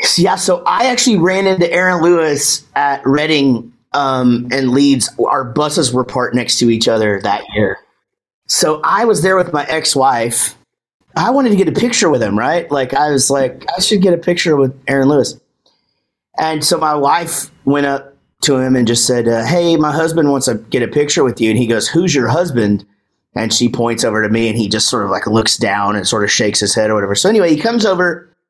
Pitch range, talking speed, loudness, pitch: 120-170 Hz, 225 wpm, -13 LUFS, 140 Hz